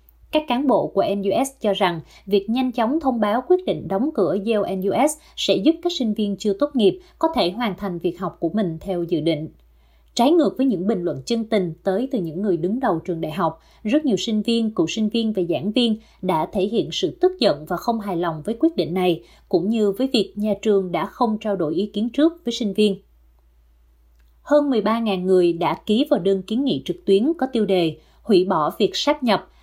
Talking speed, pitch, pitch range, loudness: 230 wpm, 205 Hz, 180-240 Hz, -21 LUFS